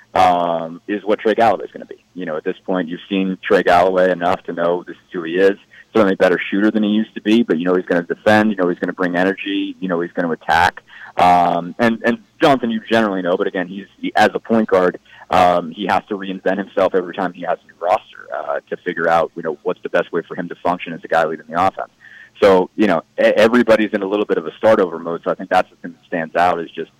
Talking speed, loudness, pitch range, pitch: 280 wpm, -17 LUFS, 90-105 Hz, 95 Hz